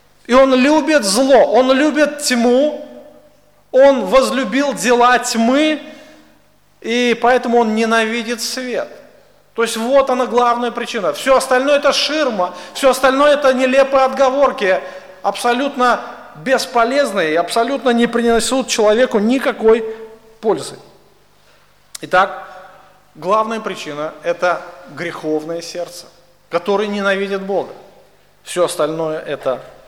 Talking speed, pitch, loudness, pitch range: 105 wpm, 240 Hz, -15 LUFS, 195-265 Hz